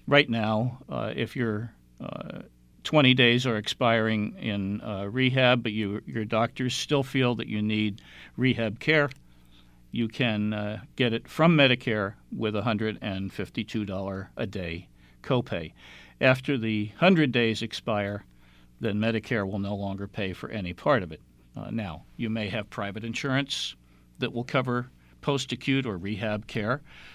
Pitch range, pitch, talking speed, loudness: 100-125 Hz, 110 Hz, 150 wpm, -27 LUFS